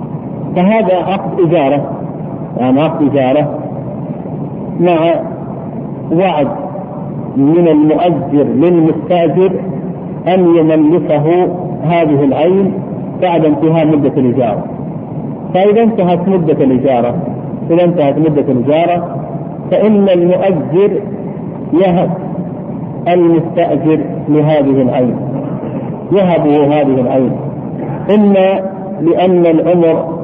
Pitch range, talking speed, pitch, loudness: 150-185 Hz, 75 wpm, 170 Hz, -12 LUFS